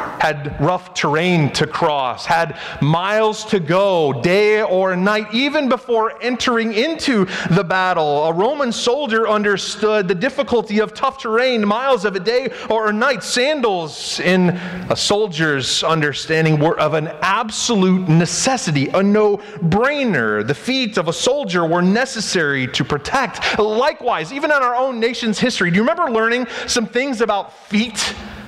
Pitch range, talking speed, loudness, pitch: 175-240 Hz, 150 wpm, -17 LUFS, 210 Hz